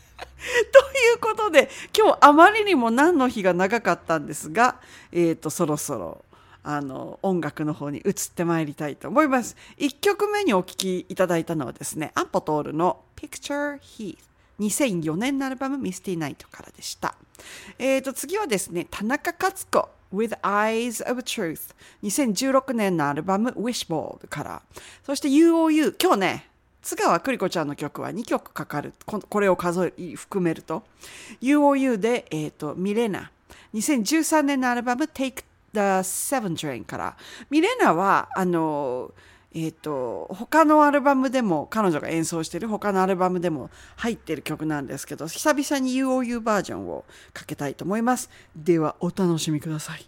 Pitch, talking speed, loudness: 205 Hz, 355 characters per minute, -23 LUFS